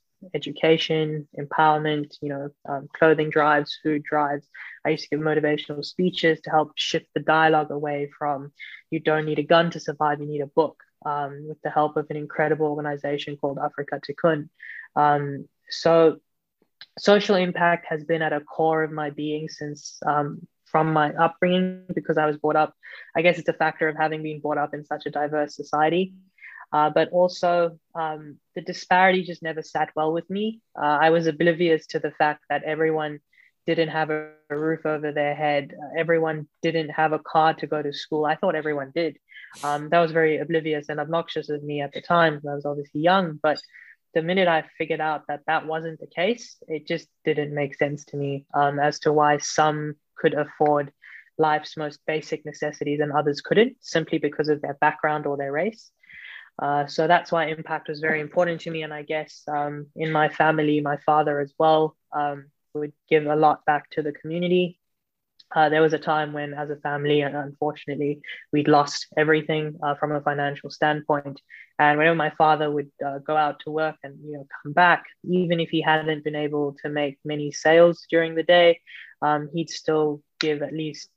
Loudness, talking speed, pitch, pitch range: -23 LUFS, 195 wpm, 155 Hz, 150-160 Hz